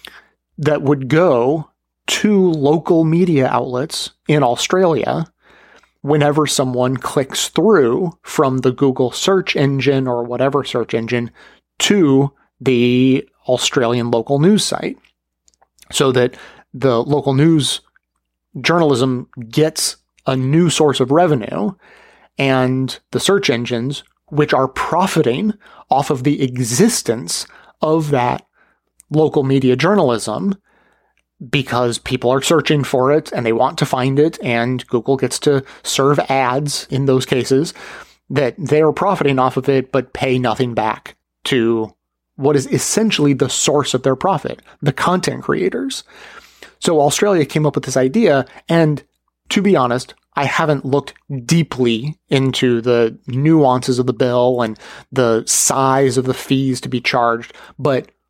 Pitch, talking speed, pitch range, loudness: 135 Hz, 135 wpm, 125-150 Hz, -16 LUFS